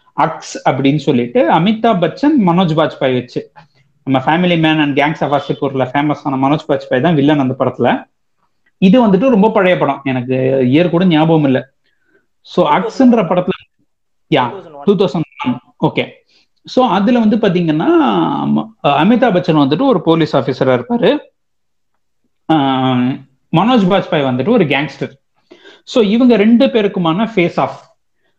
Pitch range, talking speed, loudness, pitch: 140-205 Hz, 100 wpm, -13 LUFS, 160 Hz